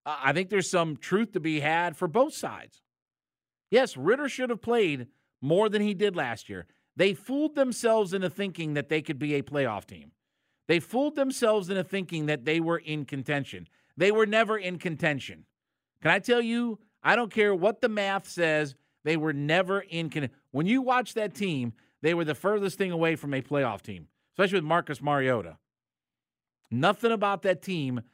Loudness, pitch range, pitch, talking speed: -27 LUFS, 145-205 Hz, 170 Hz, 190 wpm